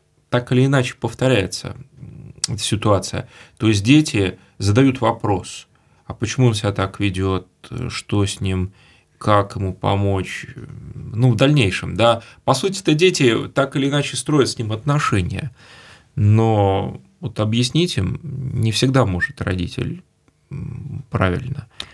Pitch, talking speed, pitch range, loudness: 120 Hz, 130 wpm, 100-135 Hz, -19 LUFS